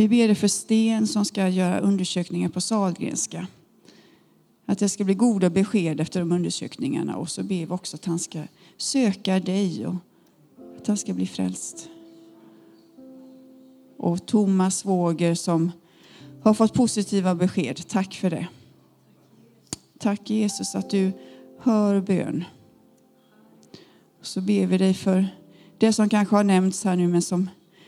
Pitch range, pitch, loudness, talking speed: 175-215 Hz, 190 Hz, -23 LUFS, 145 wpm